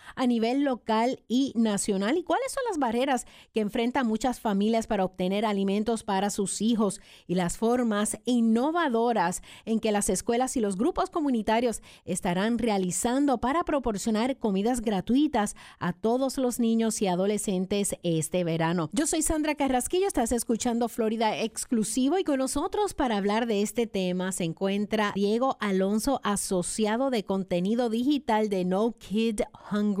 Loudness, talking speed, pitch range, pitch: -27 LUFS, 150 wpm, 200-250 Hz, 225 Hz